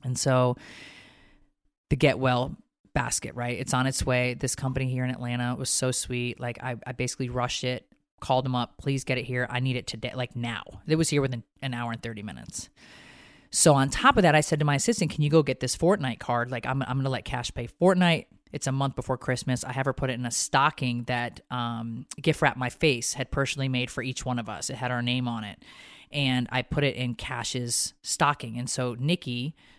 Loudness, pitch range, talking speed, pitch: -27 LUFS, 120-135 Hz, 235 wpm, 125 Hz